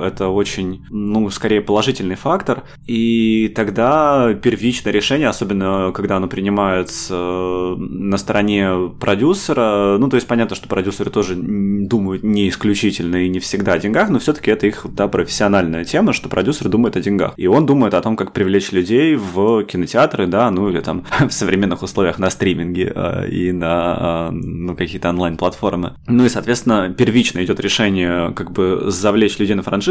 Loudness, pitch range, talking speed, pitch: -17 LUFS, 90-110 Hz, 160 wpm, 100 Hz